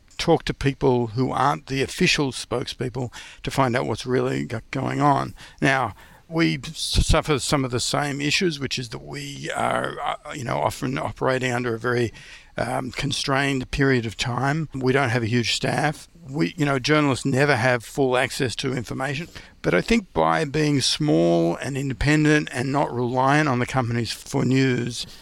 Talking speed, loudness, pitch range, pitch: 170 wpm, -23 LUFS, 125-145 Hz, 135 Hz